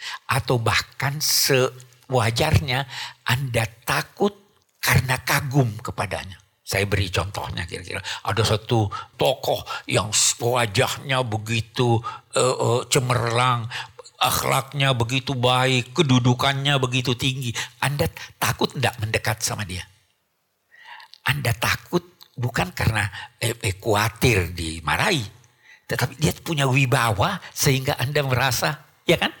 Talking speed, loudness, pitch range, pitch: 100 wpm, -22 LUFS, 110-135 Hz, 125 Hz